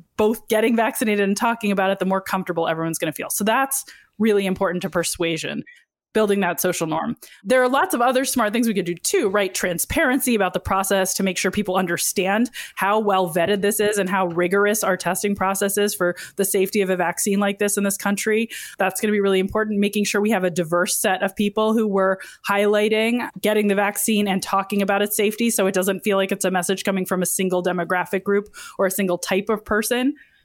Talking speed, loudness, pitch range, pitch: 225 wpm, -21 LUFS, 190-215 Hz, 200 Hz